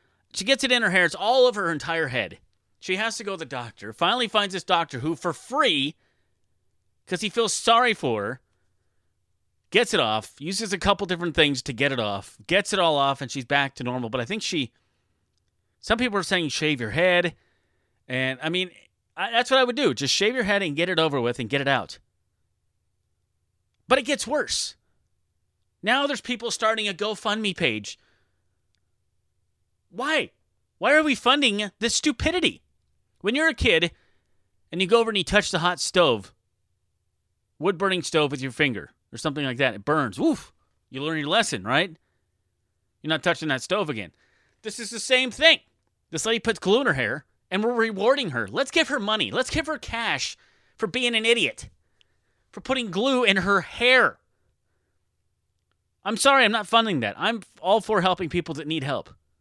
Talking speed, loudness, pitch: 190 wpm, -23 LUFS, 160 Hz